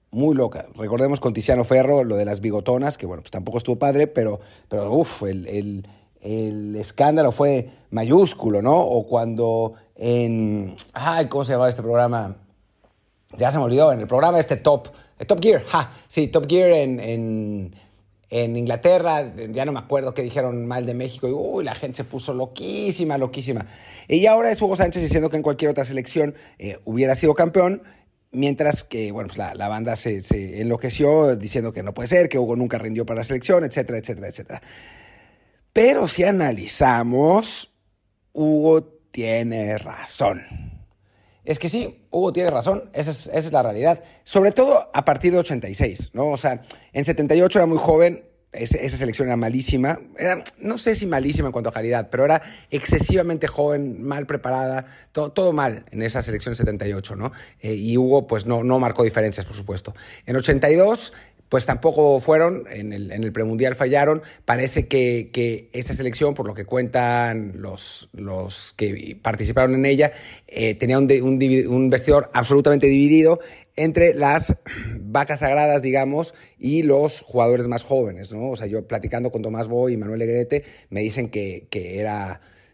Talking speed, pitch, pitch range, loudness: 175 wpm, 125 Hz, 110-150 Hz, -20 LUFS